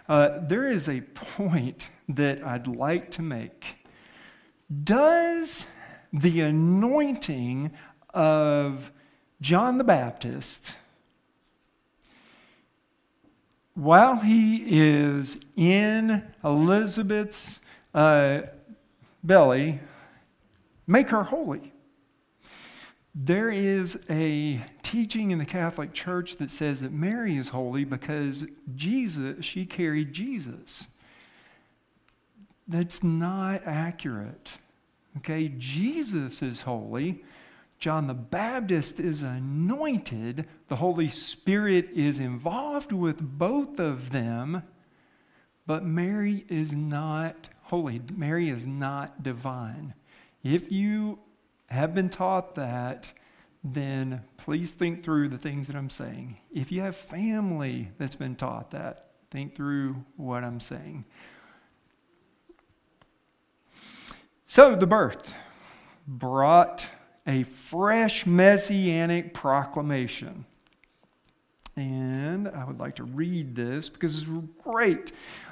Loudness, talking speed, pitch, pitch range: -26 LUFS, 95 wpm, 160 Hz, 140-190 Hz